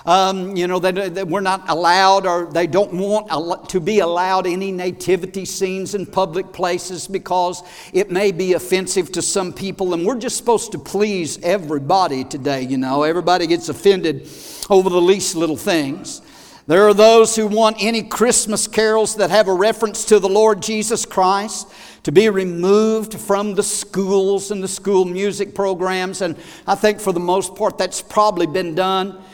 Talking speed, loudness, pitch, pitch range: 175 wpm, -17 LUFS, 190 Hz, 180-205 Hz